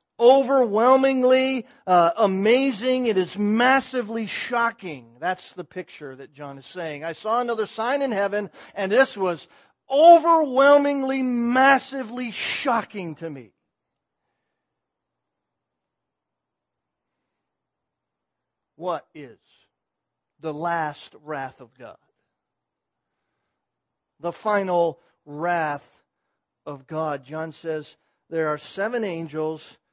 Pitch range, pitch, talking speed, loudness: 160-250 Hz, 200 Hz, 90 wpm, -22 LUFS